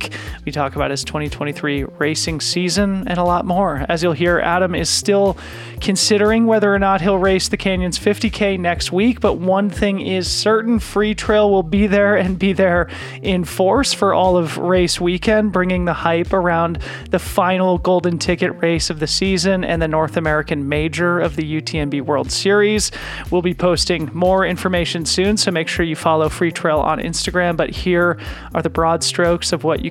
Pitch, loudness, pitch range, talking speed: 180 Hz, -17 LUFS, 165-195 Hz, 190 wpm